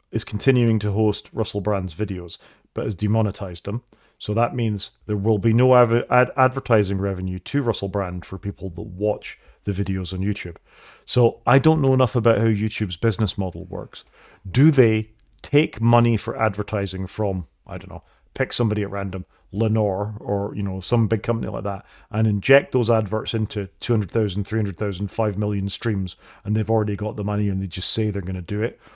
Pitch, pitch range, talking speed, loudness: 105 Hz, 100-115 Hz, 190 wpm, -22 LUFS